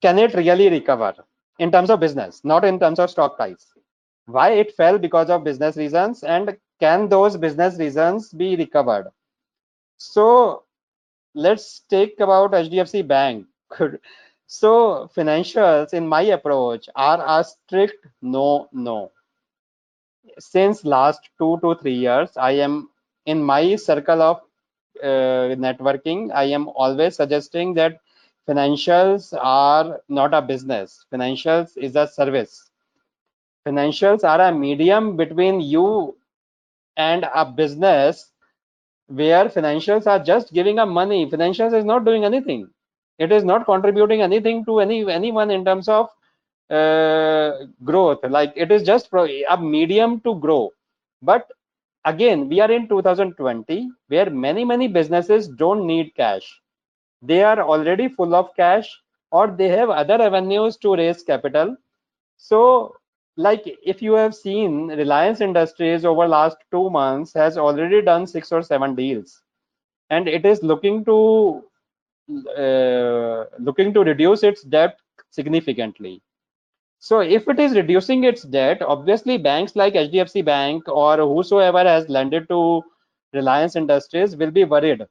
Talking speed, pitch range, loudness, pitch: 135 wpm, 150-205 Hz, -18 LUFS, 170 Hz